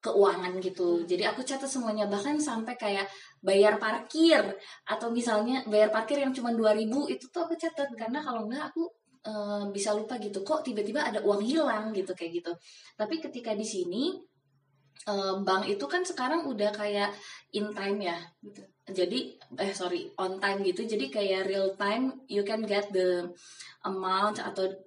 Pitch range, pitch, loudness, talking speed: 190-250 Hz, 210 Hz, -30 LUFS, 165 wpm